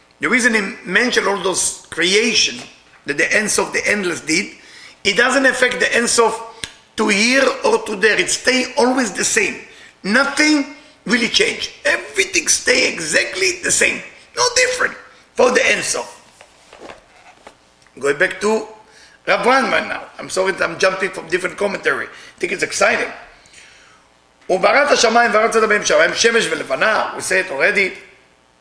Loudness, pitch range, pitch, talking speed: -16 LUFS, 195-275 Hz, 230 Hz, 140 wpm